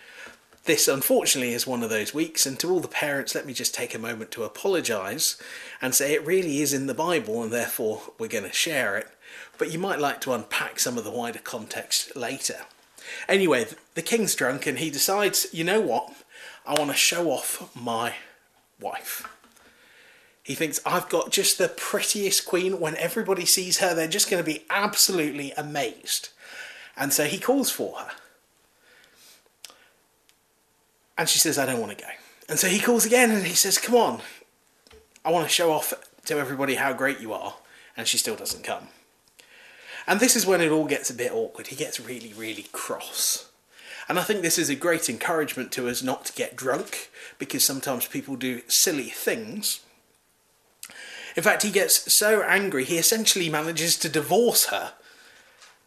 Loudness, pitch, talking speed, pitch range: -24 LUFS, 185 Hz, 185 wpm, 150-225 Hz